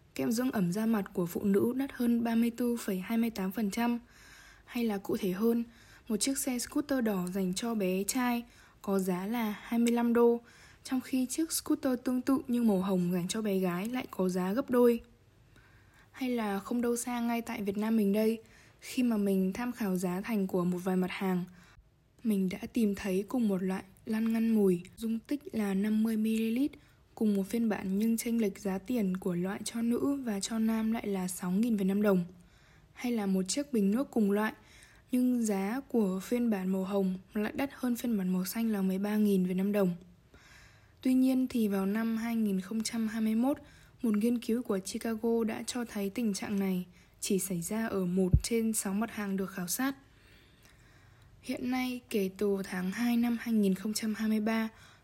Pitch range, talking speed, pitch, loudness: 195-235 Hz, 185 wpm, 220 Hz, -32 LUFS